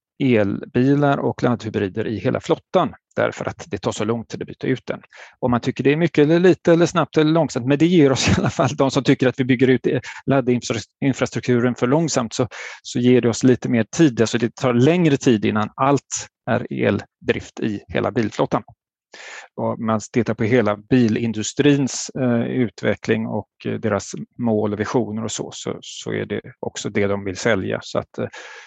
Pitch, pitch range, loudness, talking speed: 125 Hz, 110-135 Hz, -20 LUFS, 195 wpm